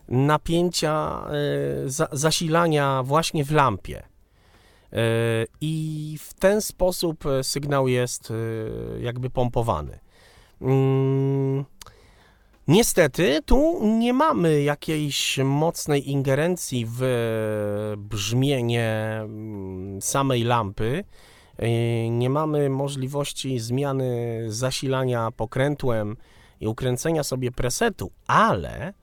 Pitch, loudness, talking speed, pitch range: 130 Hz, -24 LUFS, 70 wpm, 115-150 Hz